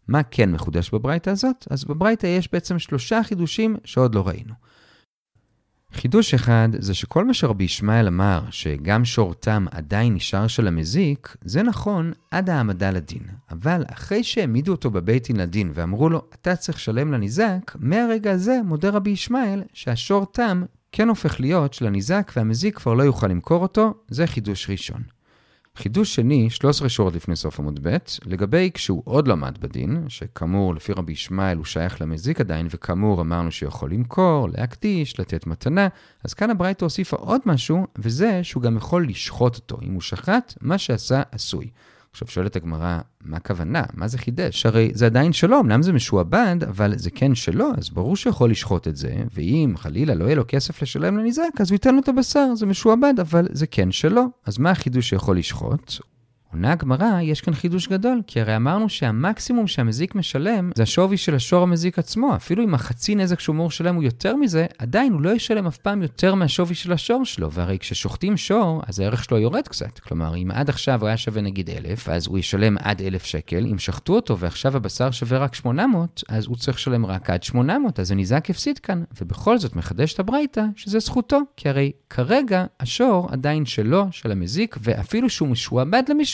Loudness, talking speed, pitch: -21 LUFS, 175 wpm, 135 Hz